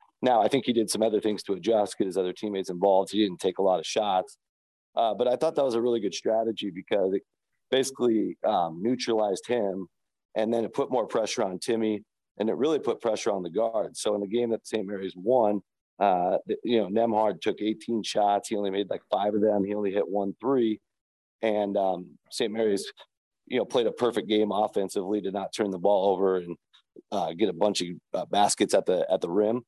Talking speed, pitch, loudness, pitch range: 225 wpm, 105 Hz, -27 LUFS, 100-115 Hz